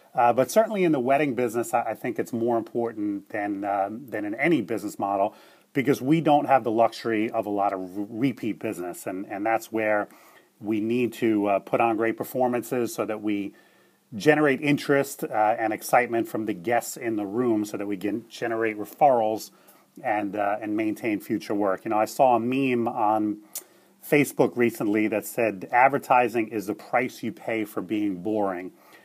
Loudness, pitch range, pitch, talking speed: -25 LUFS, 105-130 Hz, 115 Hz, 190 wpm